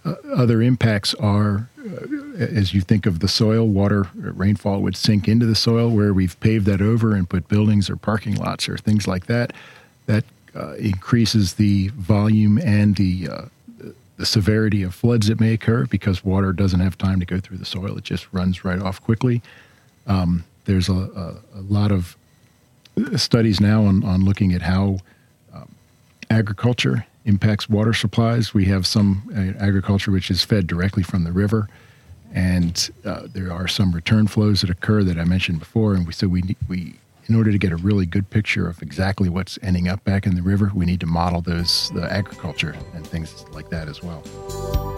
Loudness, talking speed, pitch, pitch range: -20 LUFS, 190 wpm, 100 Hz, 95-110 Hz